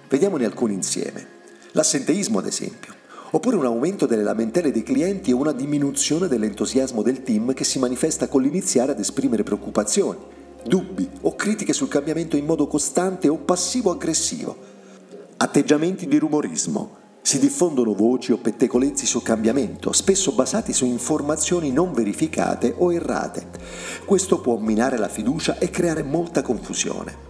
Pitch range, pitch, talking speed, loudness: 125-175 Hz, 145 Hz, 140 wpm, -21 LUFS